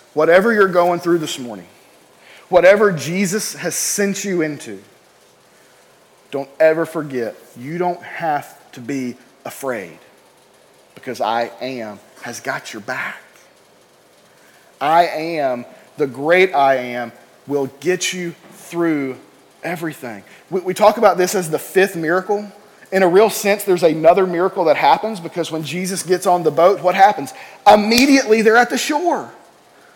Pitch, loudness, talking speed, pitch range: 175 Hz, -17 LUFS, 140 wpm, 155-195 Hz